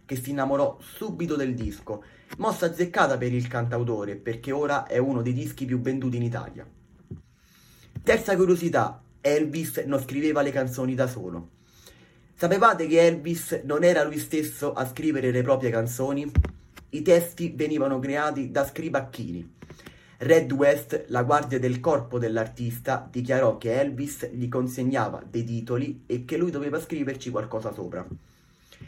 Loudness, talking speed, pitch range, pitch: -26 LUFS, 145 wpm, 125-155 Hz, 135 Hz